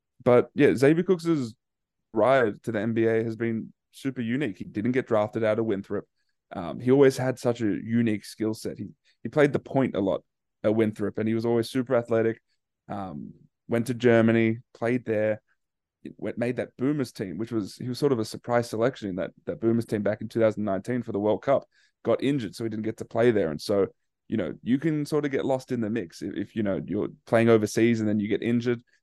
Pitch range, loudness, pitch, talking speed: 110-125 Hz, -26 LUFS, 115 Hz, 225 wpm